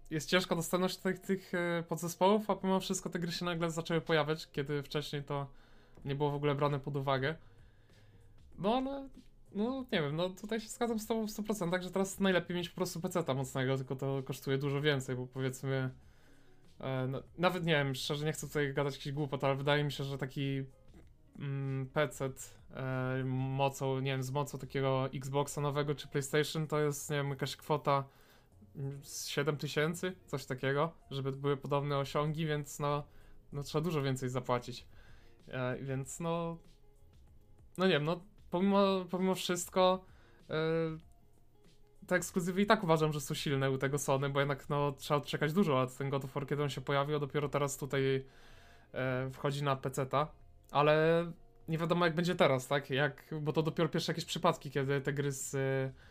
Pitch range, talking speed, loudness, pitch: 135-170 Hz, 180 wpm, -35 LUFS, 145 Hz